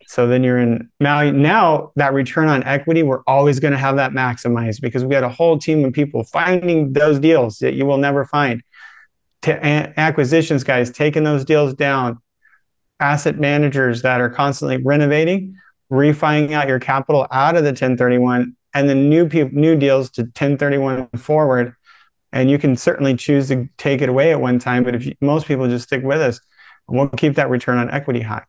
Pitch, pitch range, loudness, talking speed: 140 Hz, 125-150 Hz, -16 LUFS, 195 wpm